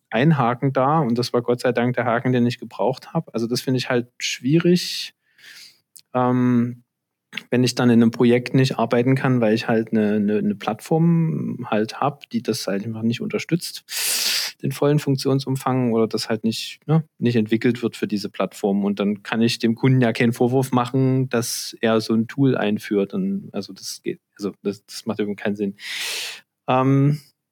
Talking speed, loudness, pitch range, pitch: 190 wpm, -21 LUFS, 115-135 Hz, 120 Hz